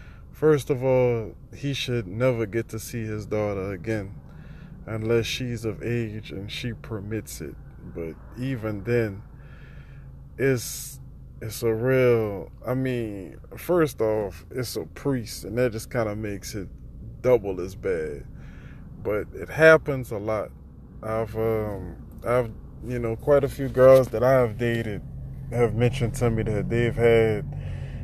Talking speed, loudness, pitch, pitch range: 145 wpm, -25 LUFS, 115 Hz, 105-125 Hz